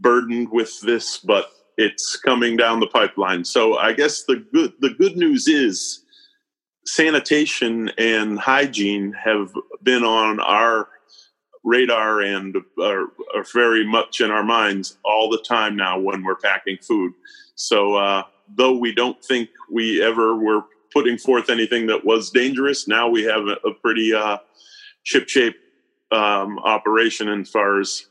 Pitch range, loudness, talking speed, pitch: 105-140 Hz, -19 LUFS, 150 wpm, 115 Hz